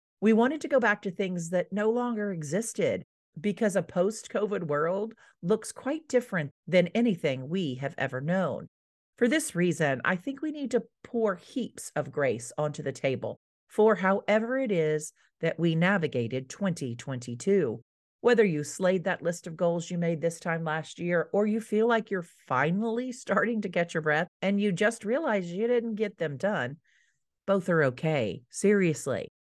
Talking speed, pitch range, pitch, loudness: 170 wpm, 160-220 Hz, 190 Hz, -28 LUFS